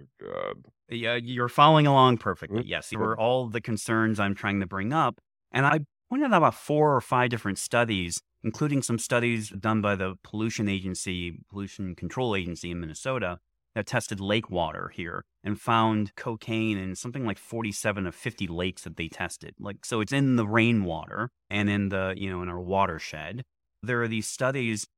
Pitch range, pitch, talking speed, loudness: 95-120 Hz, 105 Hz, 185 wpm, -27 LUFS